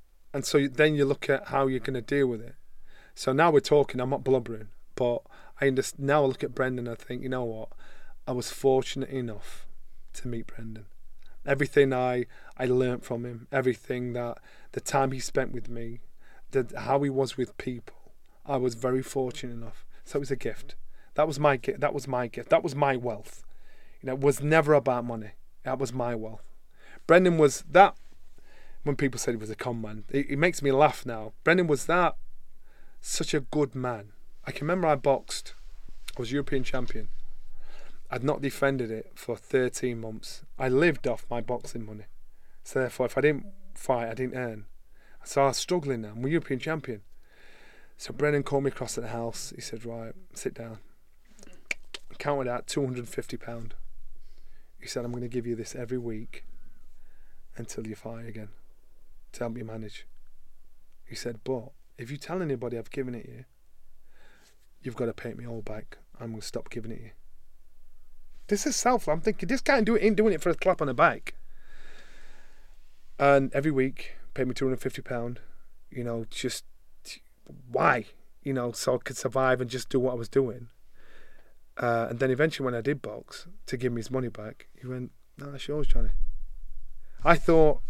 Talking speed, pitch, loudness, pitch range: 195 wpm, 125 Hz, -28 LUFS, 115-140 Hz